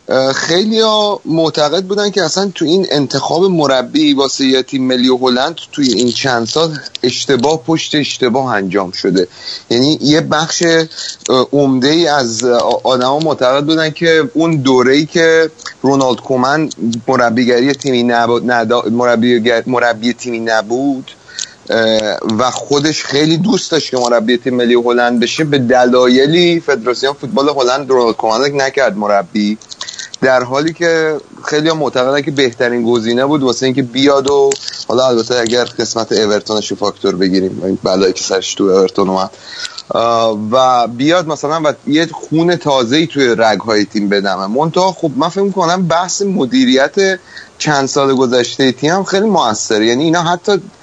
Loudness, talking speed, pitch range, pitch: -12 LUFS, 145 wpm, 120-155 Hz, 135 Hz